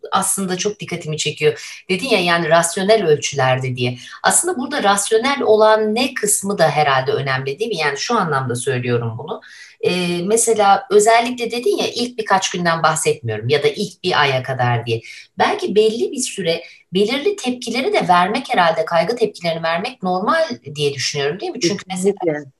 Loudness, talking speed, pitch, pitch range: -17 LUFS, 160 wpm, 185 Hz, 150-220 Hz